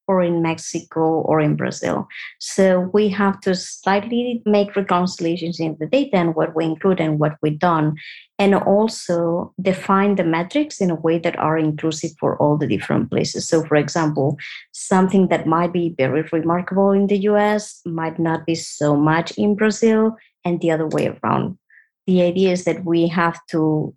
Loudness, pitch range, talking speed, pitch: -19 LUFS, 160-195 Hz, 180 wpm, 170 Hz